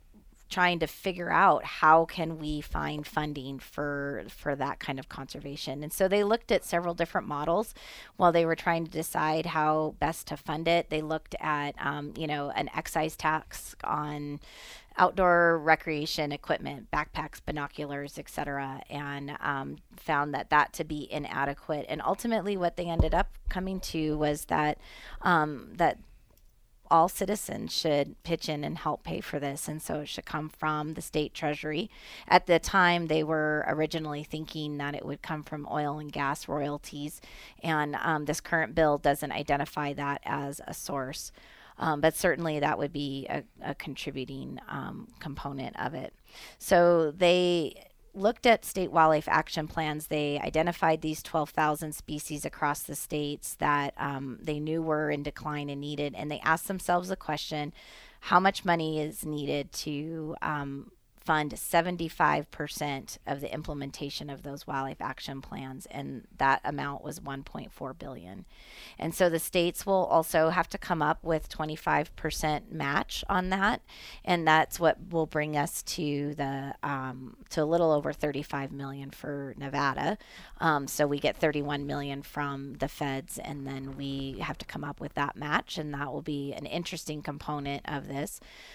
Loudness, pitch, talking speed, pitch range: -30 LUFS, 150 Hz, 165 wpm, 145-165 Hz